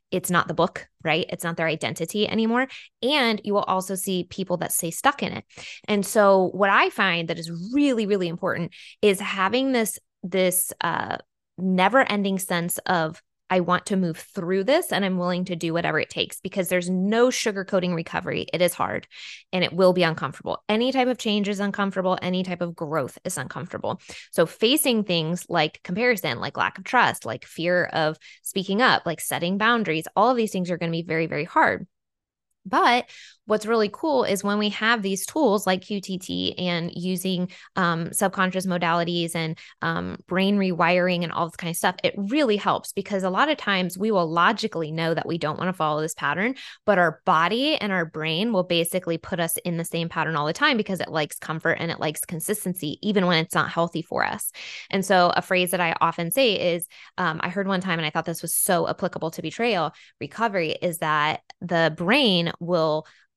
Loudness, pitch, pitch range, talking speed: -23 LUFS, 180 Hz, 165-205 Hz, 205 wpm